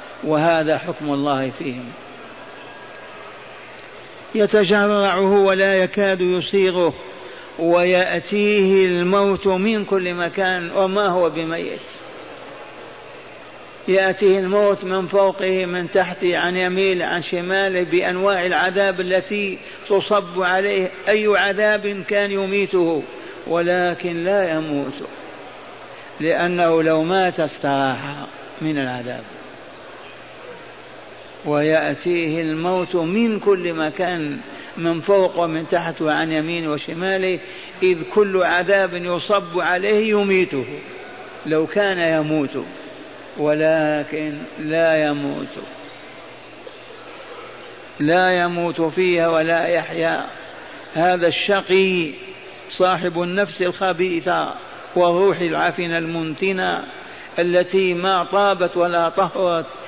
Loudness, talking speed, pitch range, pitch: -19 LUFS, 85 wpm, 165-195 Hz, 180 Hz